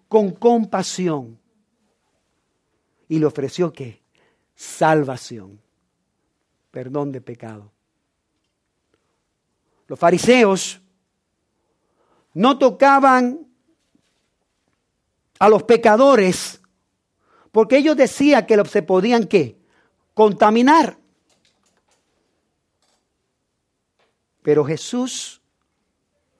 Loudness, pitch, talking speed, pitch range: -16 LUFS, 200 Hz, 60 wpm, 150-240 Hz